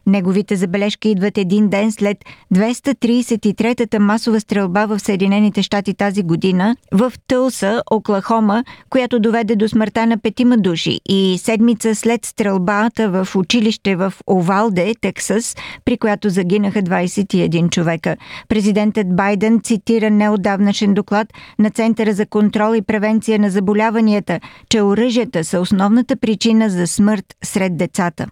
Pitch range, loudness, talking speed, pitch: 200-225 Hz, -16 LUFS, 125 wpm, 210 Hz